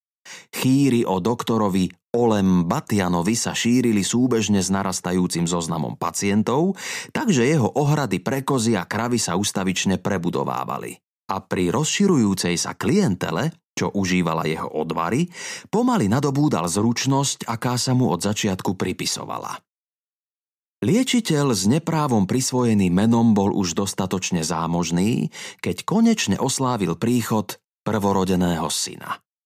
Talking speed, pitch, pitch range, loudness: 110 wpm, 105 Hz, 90-125 Hz, -21 LUFS